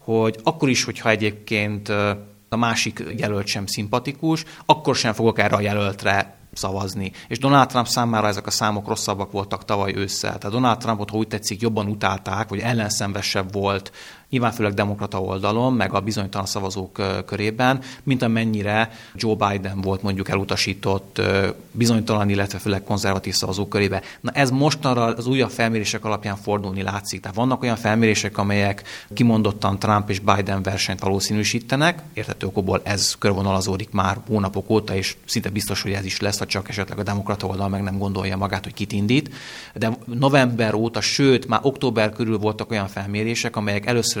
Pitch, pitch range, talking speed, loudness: 105 Hz, 100-115 Hz, 160 wpm, -22 LUFS